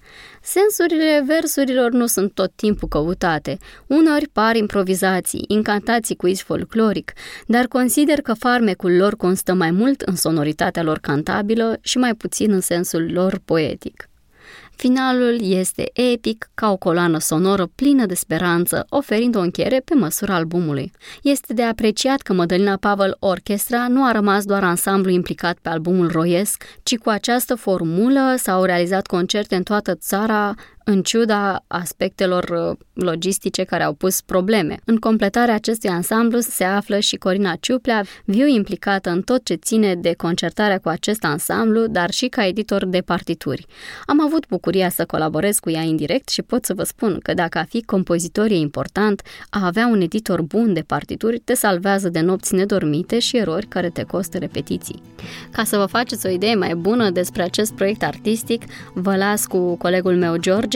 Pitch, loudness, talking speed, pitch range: 195 Hz, -19 LUFS, 165 wpm, 175-225 Hz